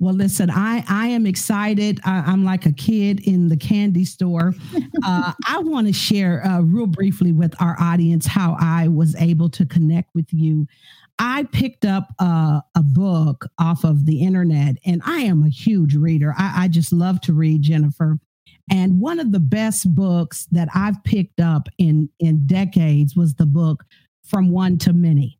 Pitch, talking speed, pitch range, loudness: 175 Hz, 180 wpm, 160-195 Hz, -18 LUFS